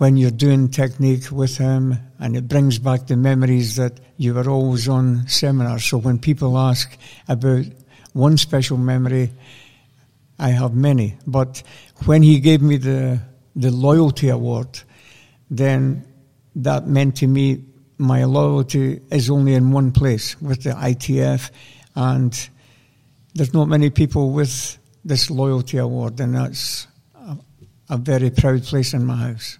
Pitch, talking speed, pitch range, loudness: 130 Hz, 145 wpm, 125-140 Hz, -18 LUFS